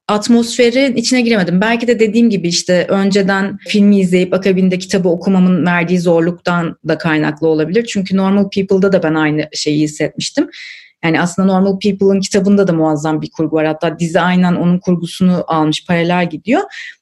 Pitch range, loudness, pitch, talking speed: 170-200 Hz, -13 LUFS, 185 Hz, 160 wpm